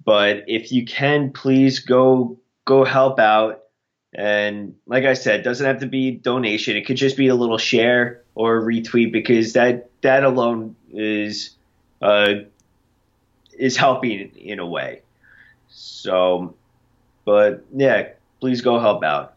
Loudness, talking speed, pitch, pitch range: -18 LUFS, 145 wpm, 120 Hz, 110-130 Hz